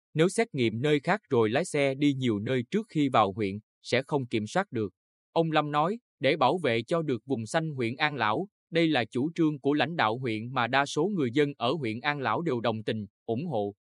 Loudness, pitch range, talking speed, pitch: -28 LUFS, 115-150 Hz, 240 wpm, 130 Hz